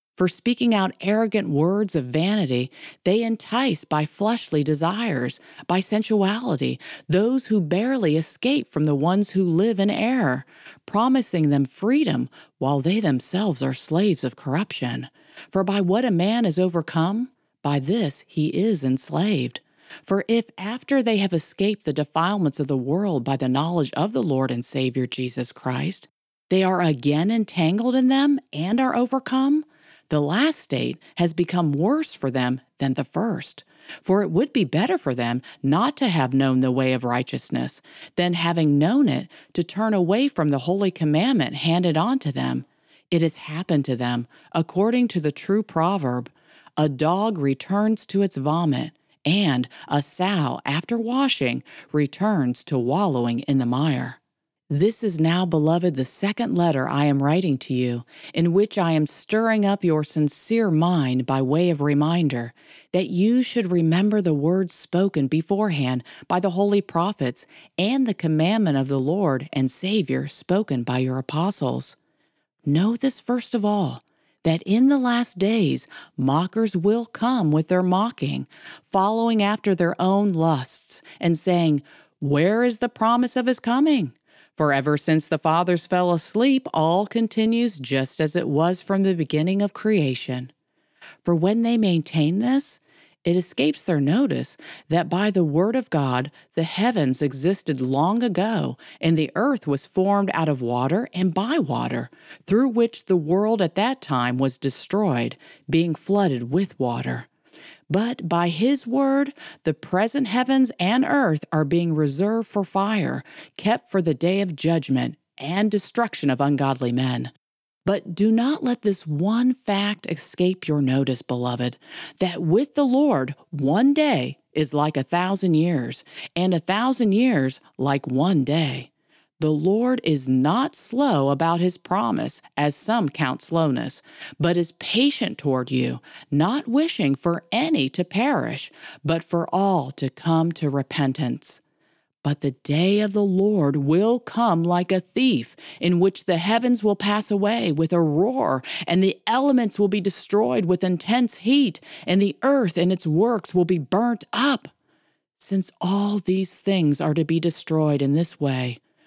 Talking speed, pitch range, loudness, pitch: 160 wpm, 150-210 Hz, -22 LUFS, 175 Hz